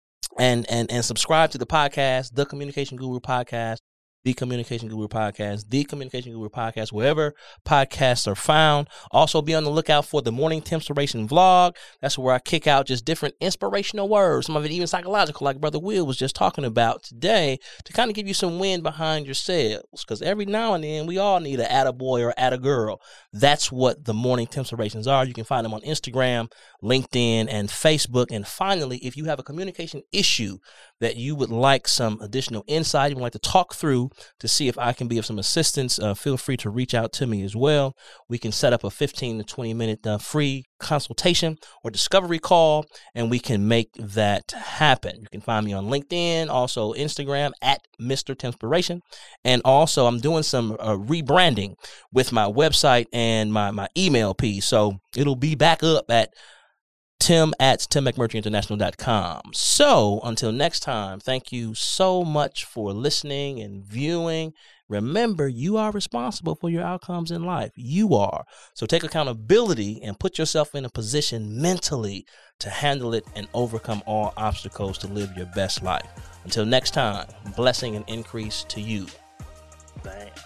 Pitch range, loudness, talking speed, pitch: 110-155 Hz, -23 LUFS, 180 wpm, 130 Hz